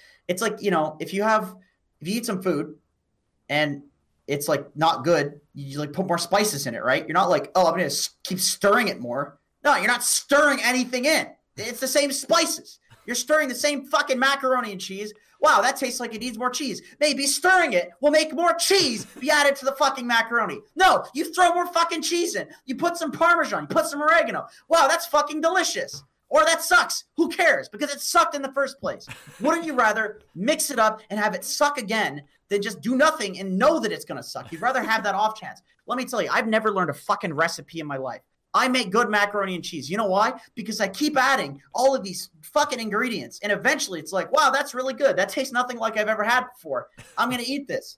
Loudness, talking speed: -23 LUFS, 235 wpm